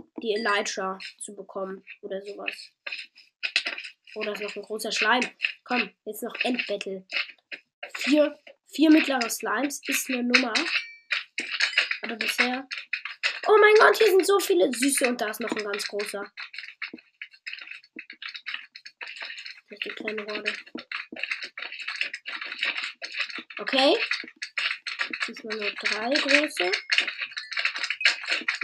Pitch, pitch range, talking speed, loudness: 240 Hz, 210-285 Hz, 90 wpm, -25 LUFS